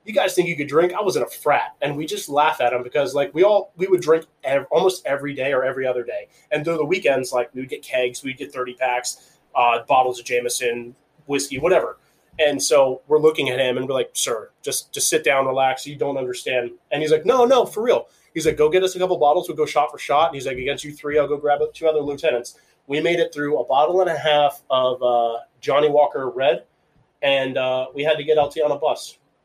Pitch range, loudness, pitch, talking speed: 130-180 Hz, -20 LUFS, 150 Hz, 255 wpm